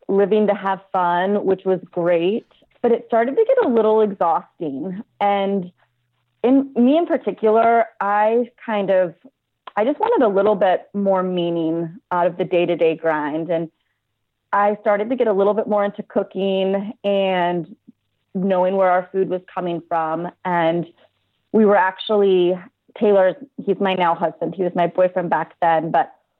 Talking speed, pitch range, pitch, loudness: 160 wpm, 175-210 Hz, 190 Hz, -19 LUFS